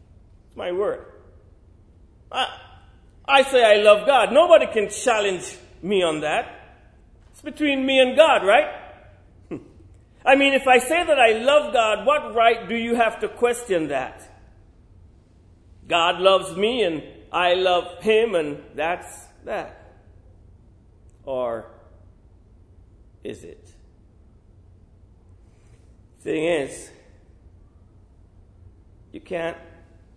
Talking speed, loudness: 105 wpm, -20 LUFS